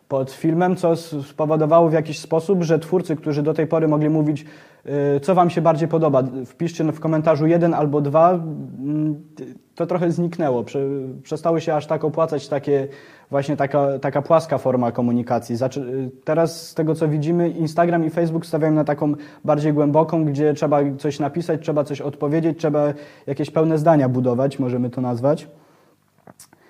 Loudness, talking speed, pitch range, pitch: -20 LUFS, 155 wpm, 140-165 Hz, 155 Hz